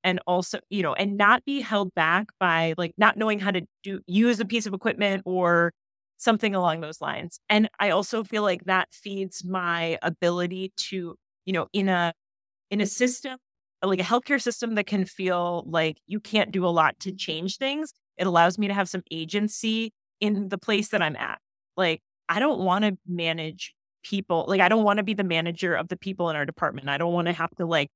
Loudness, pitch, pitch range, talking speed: -25 LUFS, 190 Hz, 170-210 Hz, 215 wpm